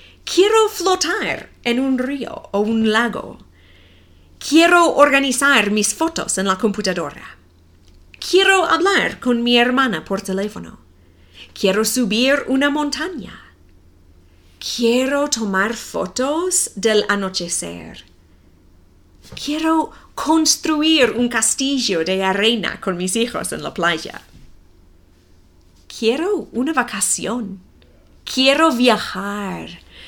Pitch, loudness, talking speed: 220 Hz, -17 LUFS, 95 wpm